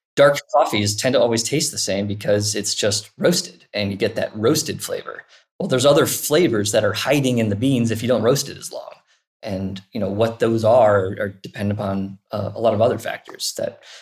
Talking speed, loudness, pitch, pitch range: 220 wpm, -20 LUFS, 105 Hz, 100-115 Hz